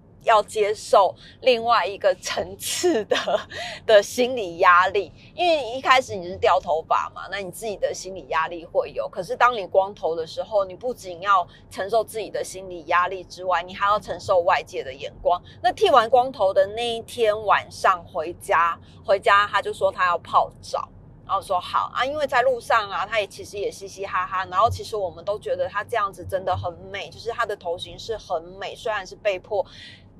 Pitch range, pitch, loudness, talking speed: 185-250 Hz, 205 Hz, -23 LUFS, 285 characters per minute